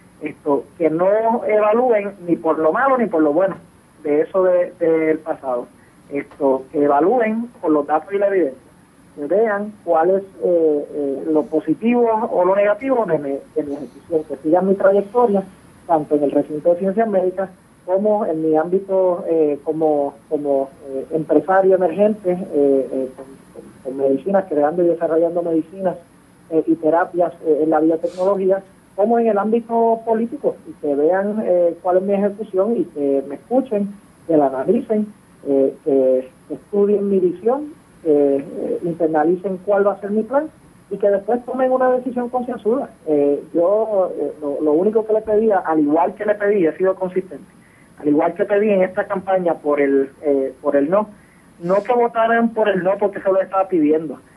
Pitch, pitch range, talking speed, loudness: 180 Hz, 155-205 Hz, 175 wpm, -18 LUFS